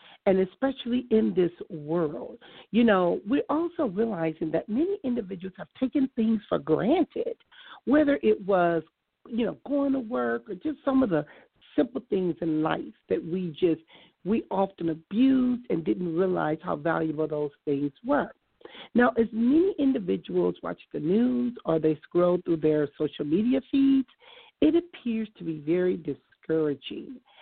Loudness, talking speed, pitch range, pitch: -27 LUFS, 155 wpm, 160-265 Hz, 200 Hz